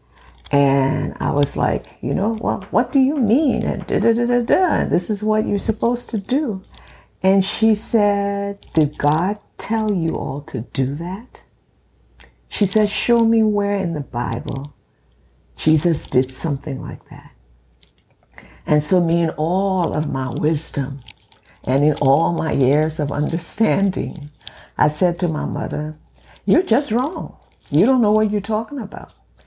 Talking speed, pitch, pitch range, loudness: 150 wpm, 160 Hz, 140-215 Hz, -19 LUFS